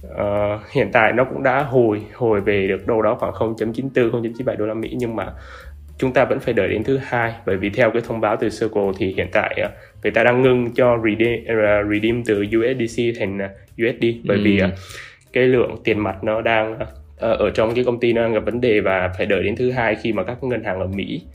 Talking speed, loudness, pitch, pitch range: 240 wpm, -19 LUFS, 110 Hz, 100-120 Hz